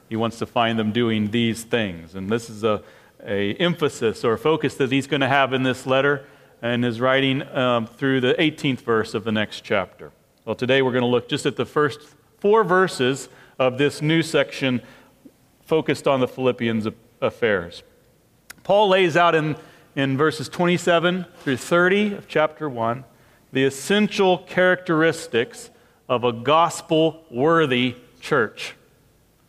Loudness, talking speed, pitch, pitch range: -21 LUFS, 155 wpm, 135 Hz, 120-160 Hz